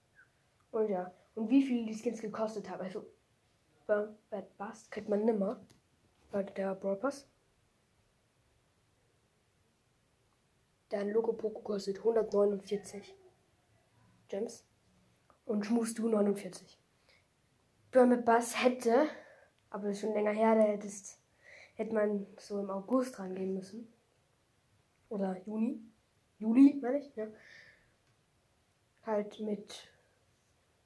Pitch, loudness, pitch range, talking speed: 210 Hz, -33 LUFS, 190-225 Hz, 95 wpm